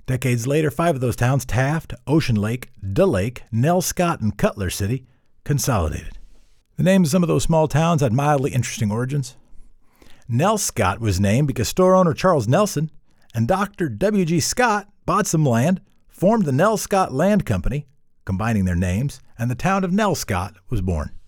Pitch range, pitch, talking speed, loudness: 110-170 Hz, 135 Hz, 175 wpm, -20 LUFS